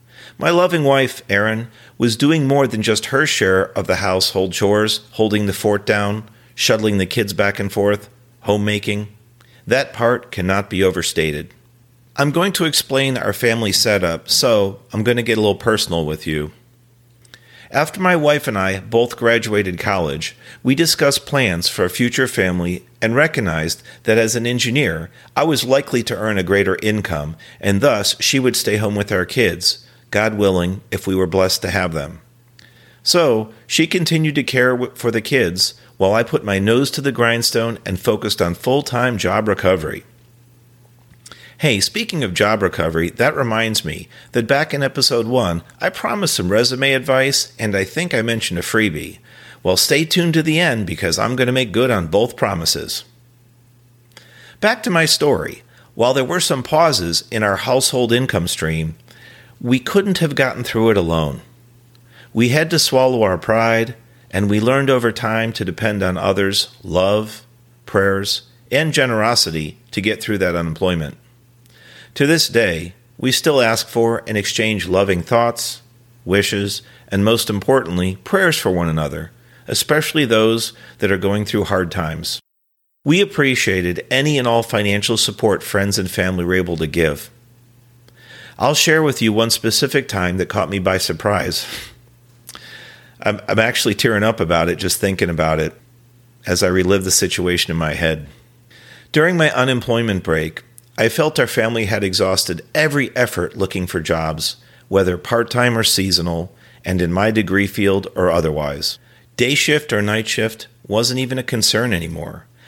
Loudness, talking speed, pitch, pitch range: -17 LUFS, 165 wpm, 115 Hz, 95-125 Hz